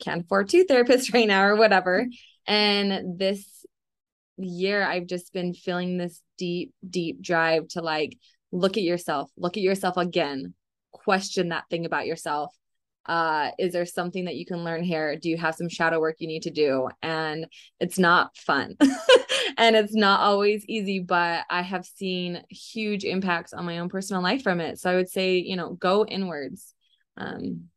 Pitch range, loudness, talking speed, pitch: 170-195 Hz, -24 LUFS, 180 wpm, 180 Hz